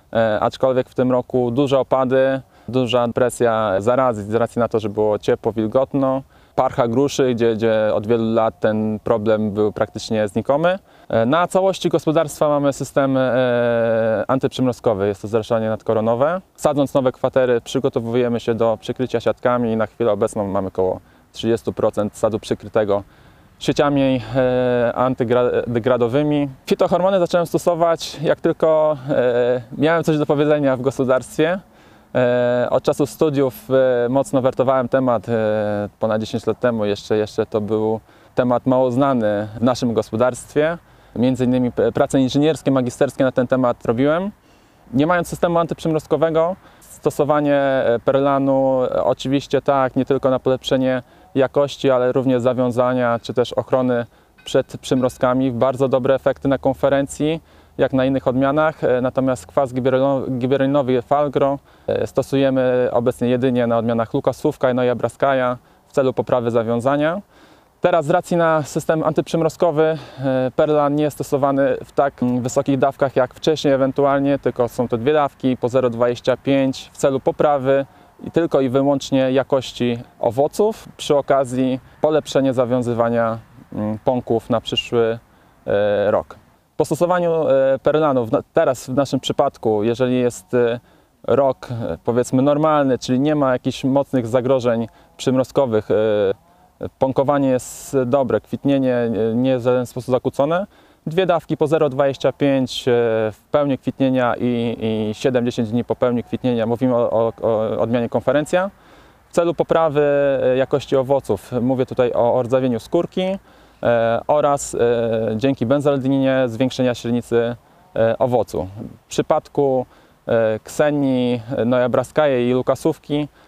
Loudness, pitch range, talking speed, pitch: -19 LUFS, 120-140 Hz, 130 wpm, 130 Hz